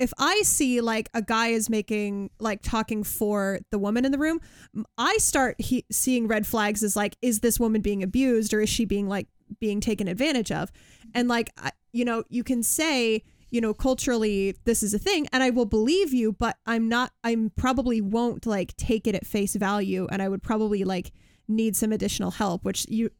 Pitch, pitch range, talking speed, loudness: 225 Hz, 210-240 Hz, 210 wpm, -25 LUFS